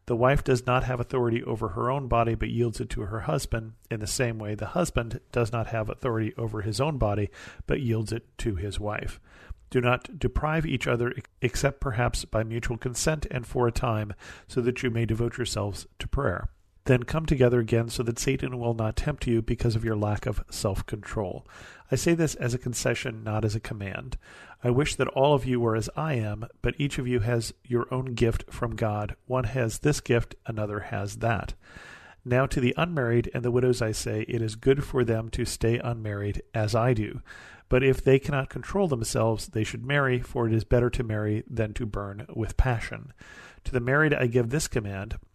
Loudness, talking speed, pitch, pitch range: -28 LUFS, 210 wpm, 120 Hz, 110-130 Hz